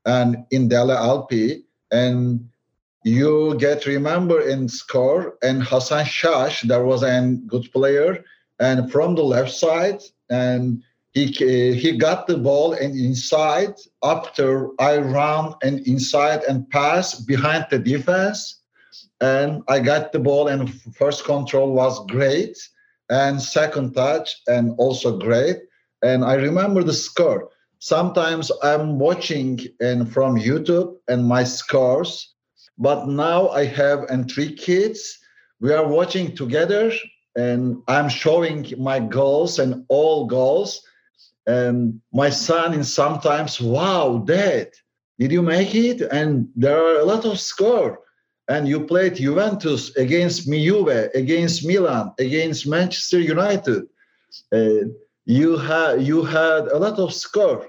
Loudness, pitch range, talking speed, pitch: -19 LUFS, 130-170 Hz, 135 wpm, 145 Hz